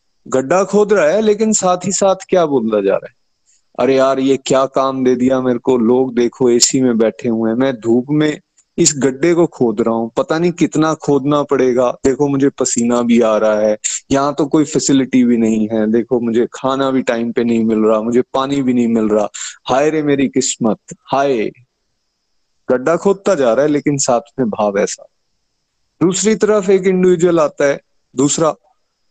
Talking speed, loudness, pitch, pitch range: 195 wpm, -14 LUFS, 135 Hz, 120-155 Hz